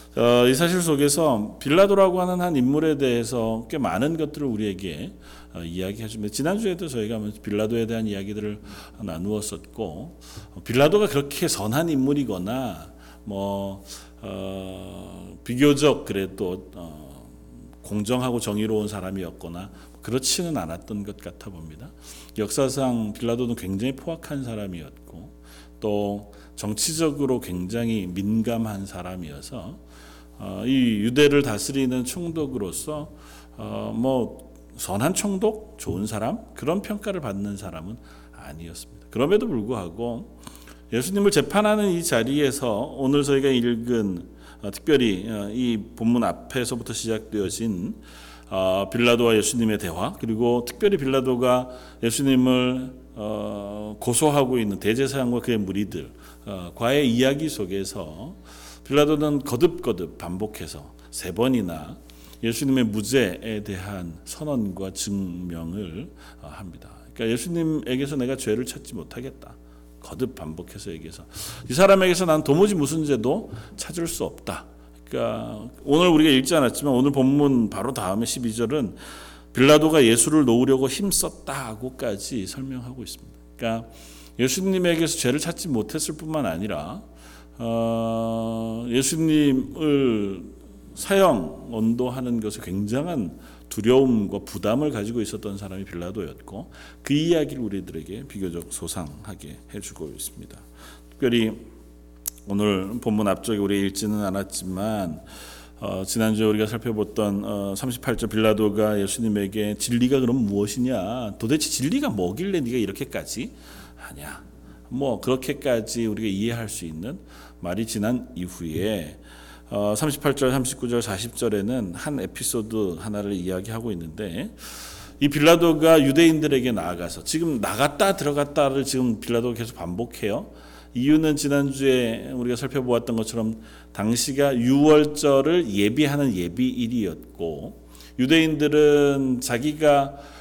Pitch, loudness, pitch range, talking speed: 115 Hz, -23 LUFS, 95-135 Hz, 295 characters per minute